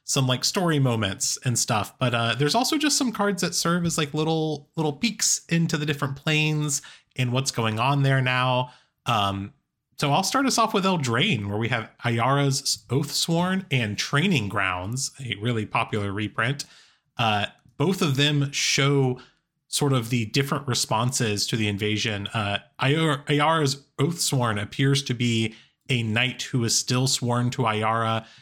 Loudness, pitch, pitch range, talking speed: -24 LUFS, 135 Hz, 115-150 Hz, 165 wpm